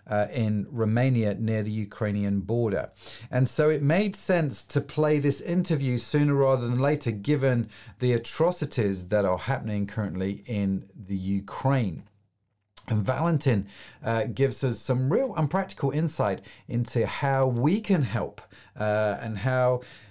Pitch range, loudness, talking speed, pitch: 105-140 Hz, -27 LUFS, 145 wpm, 120 Hz